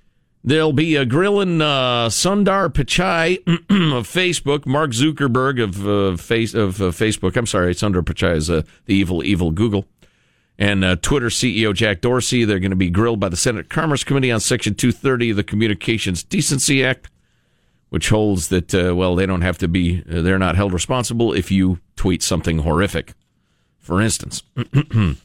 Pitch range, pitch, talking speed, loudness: 95-130 Hz, 110 Hz, 175 wpm, -18 LUFS